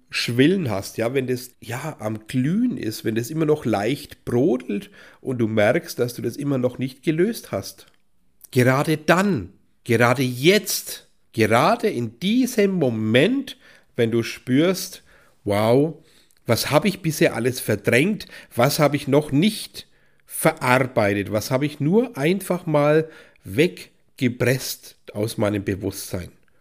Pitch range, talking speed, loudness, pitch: 115-160 Hz, 135 wpm, -21 LUFS, 130 Hz